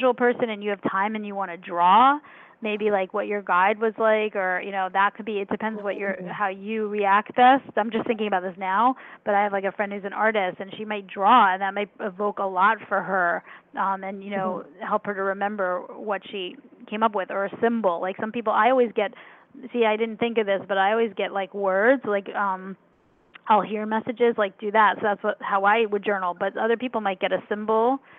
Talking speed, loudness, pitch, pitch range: 245 wpm, -24 LUFS, 205 Hz, 195-225 Hz